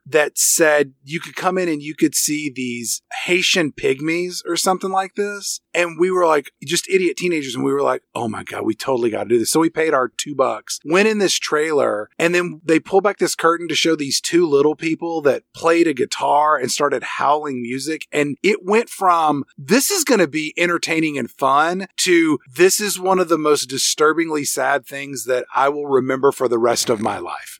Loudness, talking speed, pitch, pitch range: -18 LUFS, 215 wpm, 160 Hz, 140-180 Hz